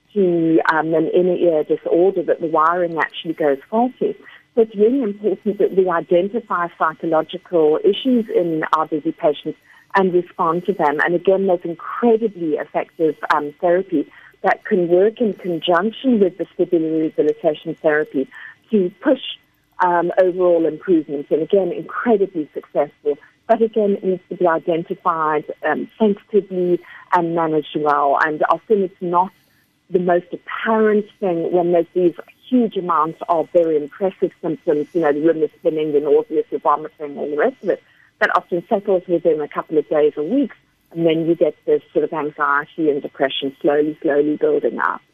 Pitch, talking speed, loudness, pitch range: 175 Hz, 160 wpm, -19 LUFS, 160-200 Hz